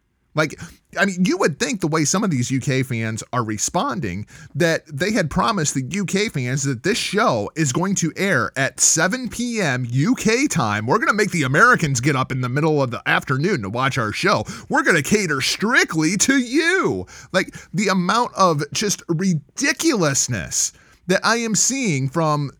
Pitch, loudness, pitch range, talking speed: 170 Hz, -19 LUFS, 140-205 Hz, 185 wpm